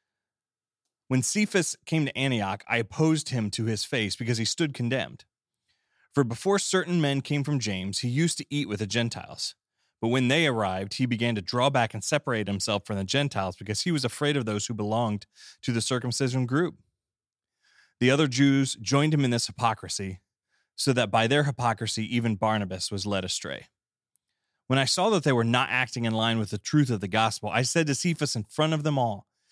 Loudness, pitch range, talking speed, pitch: -26 LUFS, 110-145 Hz, 200 wpm, 120 Hz